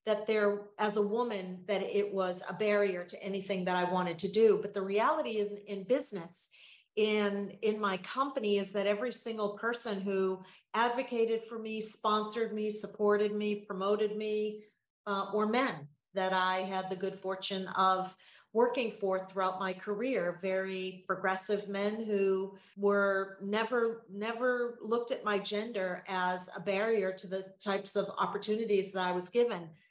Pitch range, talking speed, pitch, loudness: 190-215 Hz, 160 wpm, 200 Hz, -33 LUFS